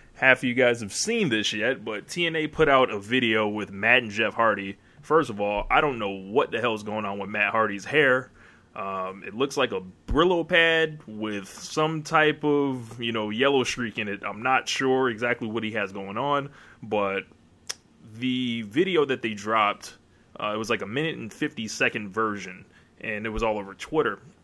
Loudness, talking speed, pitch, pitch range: -25 LUFS, 205 wpm, 115 Hz, 105-130 Hz